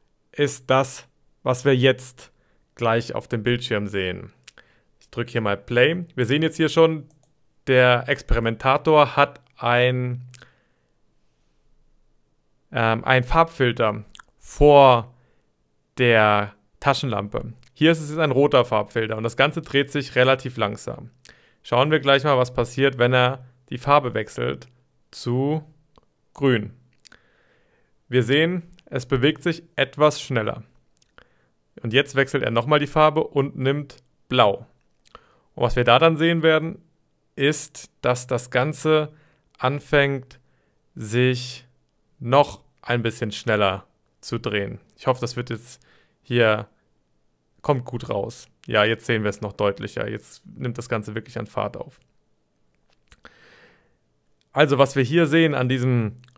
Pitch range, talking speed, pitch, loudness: 115-145 Hz, 130 wpm, 125 Hz, -21 LUFS